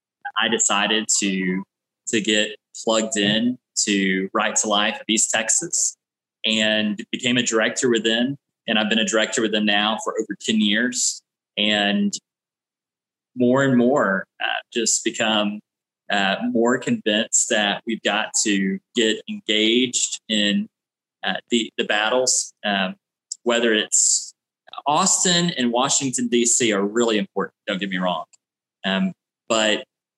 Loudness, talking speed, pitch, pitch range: -20 LUFS, 135 wpm, 110 Hz, 105-120 Hz